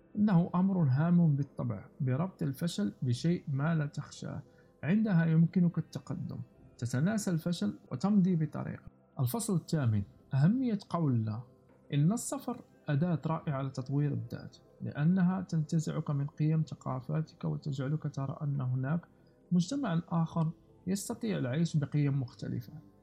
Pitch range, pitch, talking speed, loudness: 140-170 Hz, 160 Hz, 110 wpm, -32 LUFS